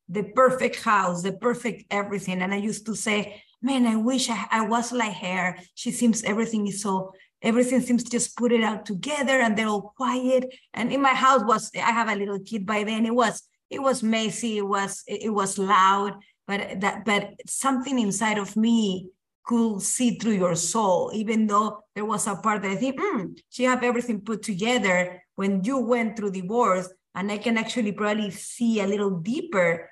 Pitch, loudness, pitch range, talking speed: 215 Hz, -24 LUFS, 200-240 Hz, 195 wpm